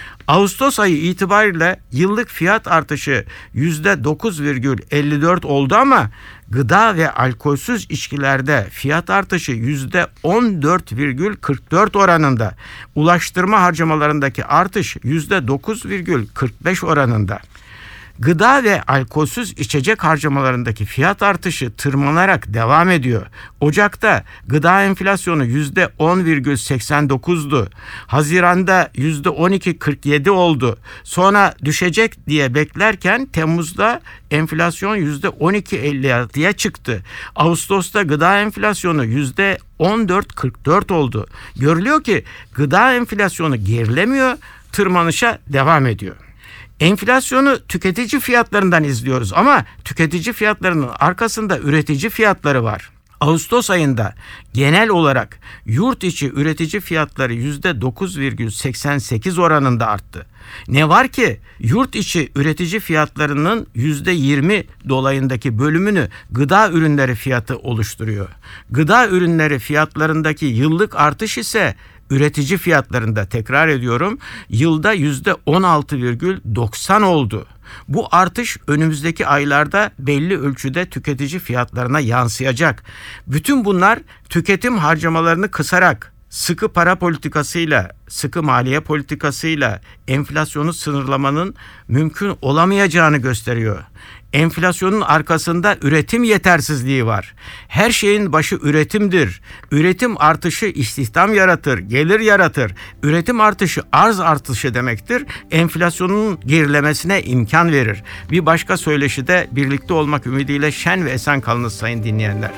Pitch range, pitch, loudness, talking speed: 130-185 Hz, 150 Hz, -16 LUFS, 95 wpm